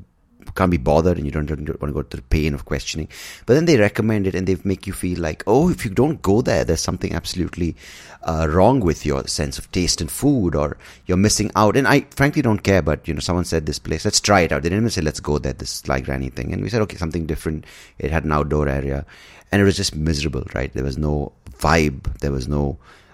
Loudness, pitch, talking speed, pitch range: -20 LUFS, 80 Hz, 255 wpm, 75-95 Hz